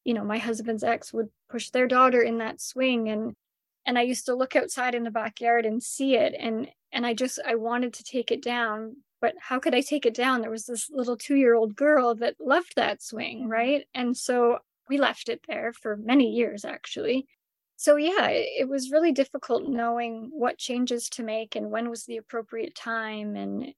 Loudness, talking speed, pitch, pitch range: -26 LUFS, 205 wpm, 240 Hz, 230-265 Hz